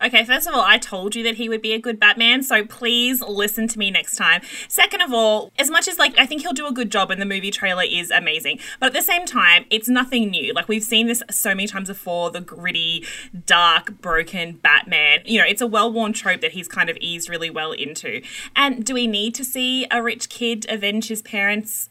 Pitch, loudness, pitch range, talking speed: 220 Hz, -18 LUFS, 195-240 Hz, 240 wpm